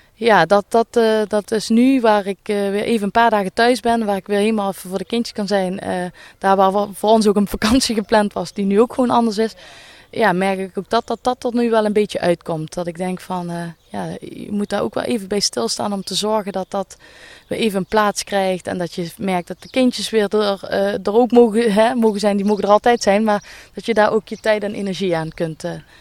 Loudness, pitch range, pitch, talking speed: -18 LUFS, 195-225 Hz, 205 Hz, 260 wpm